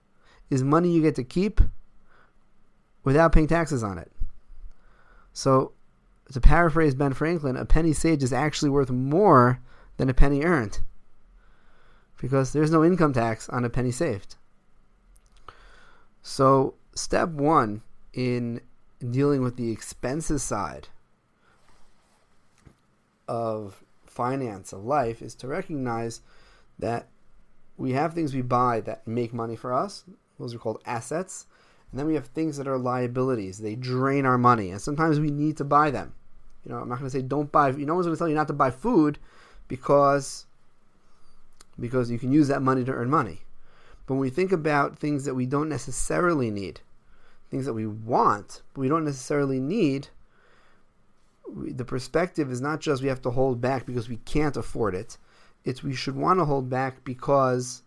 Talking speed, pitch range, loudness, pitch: 165 wpm, 125-150 Hz, -25 LUFS, 135 Hz